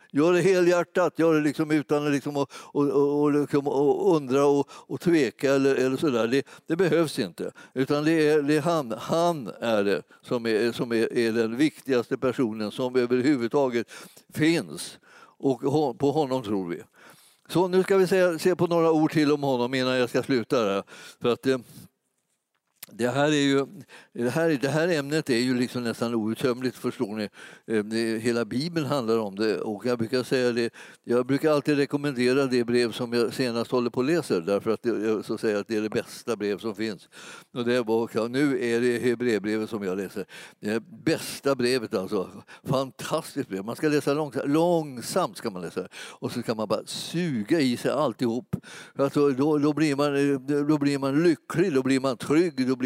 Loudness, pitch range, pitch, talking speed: -25 LUFS, 120-150 Hz, 135 Hz, 190 wpm